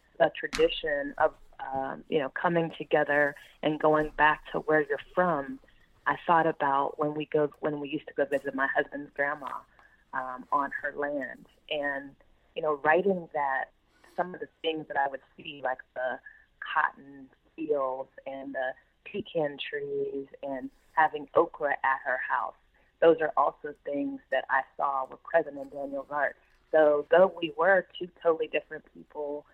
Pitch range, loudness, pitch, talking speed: 140-160 Hz, -29 LUFS, 150 Hz, 165 wpm